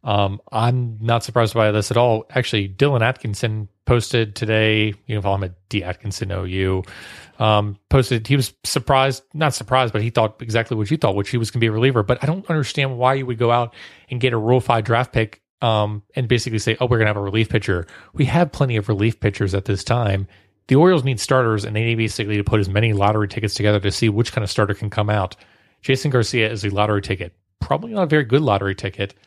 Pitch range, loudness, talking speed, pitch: 105-125 Hz, -20 LUFS, 240 wpm, 110 Hz